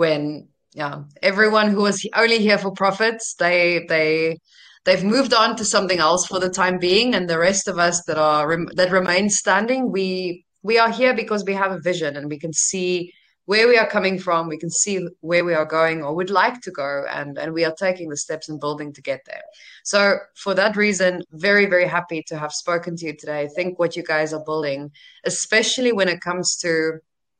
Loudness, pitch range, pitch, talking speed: -20 LUFS, 160-200 Hz, 180 Hz, 215 wpm